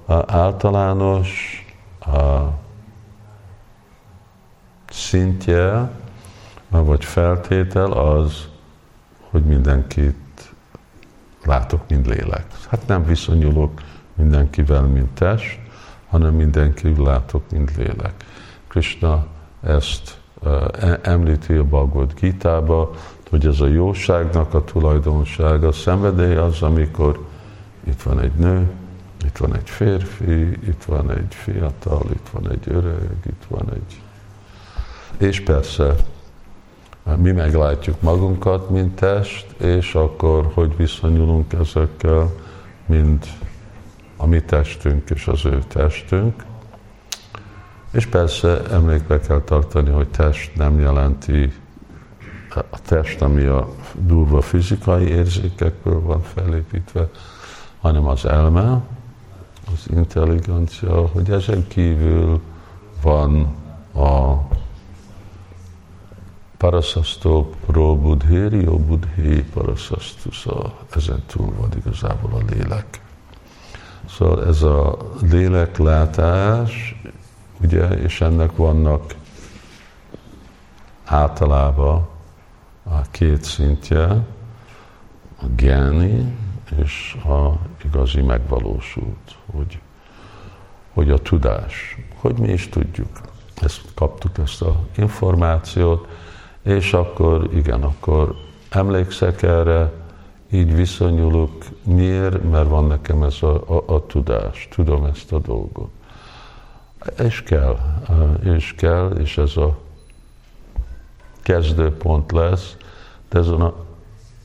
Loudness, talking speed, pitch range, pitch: -18 LUFS, 95 wpm, 75-95 Hz, 85 Hz